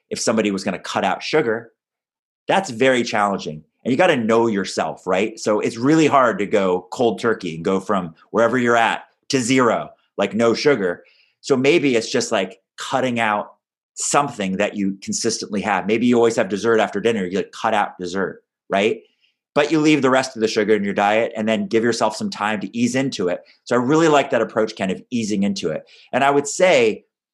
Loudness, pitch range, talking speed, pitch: -19 LUFS, 100-130 Hz, 215 wpm, 115 Hz